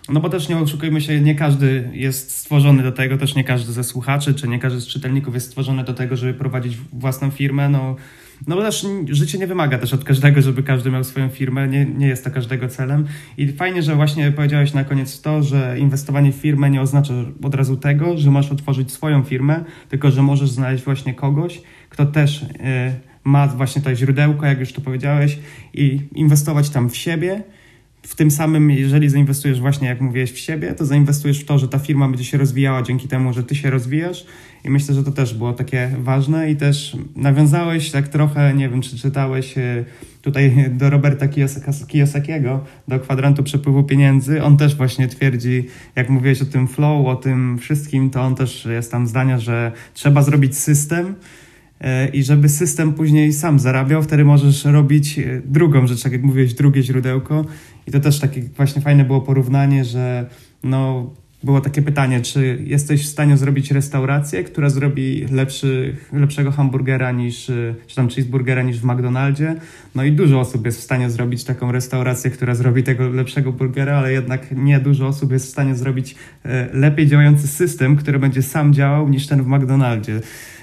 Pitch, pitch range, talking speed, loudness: 135 Hz, 130-145 Hz, 185 wpm, -17 LUFS